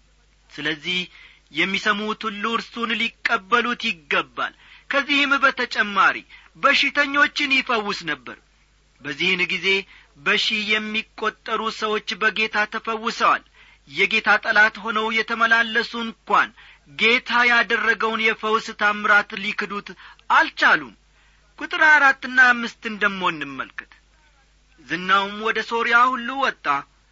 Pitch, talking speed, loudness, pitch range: 220 Hz, 85 wpm, -20 LUFS, 205-235 Hz